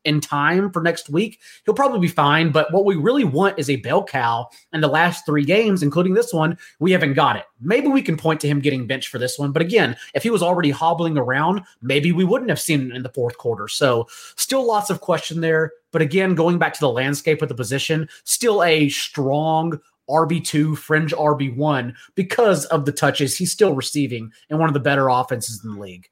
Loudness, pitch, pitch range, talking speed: -19 LUFS, 160 Hz, 145-180 Hz, 225 wpm